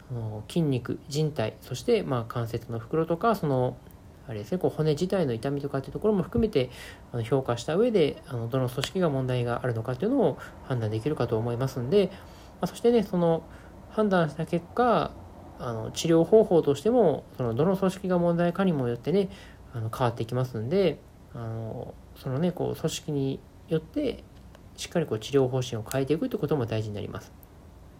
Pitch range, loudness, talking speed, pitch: 115-170 Hz, -27 LUFS, 375 characters per minute, 135 Hz